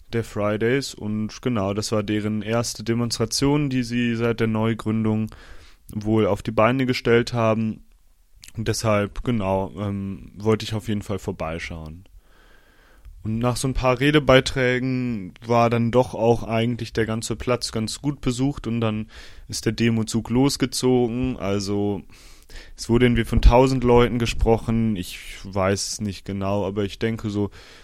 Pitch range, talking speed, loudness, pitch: 100-120 Hz, 150 wpm, -22 LUFS, 110 Hz